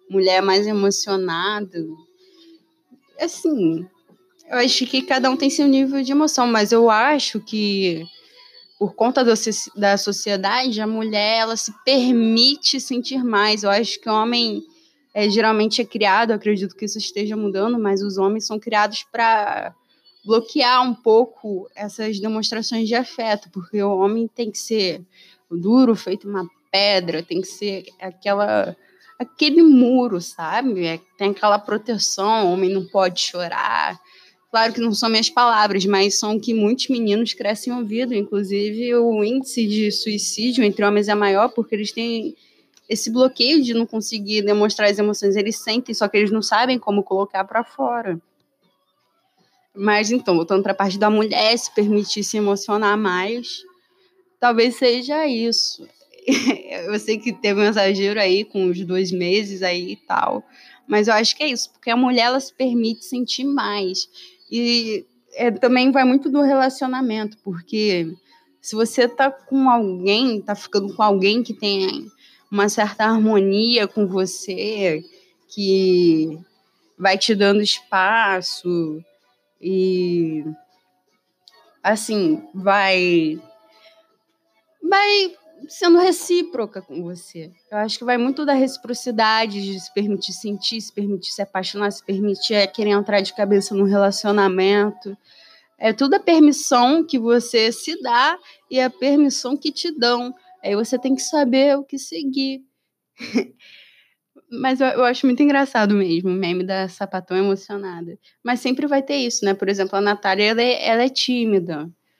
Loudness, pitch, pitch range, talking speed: -19 LUFS, 215 Hz, 195-250 Hz, 150 wpm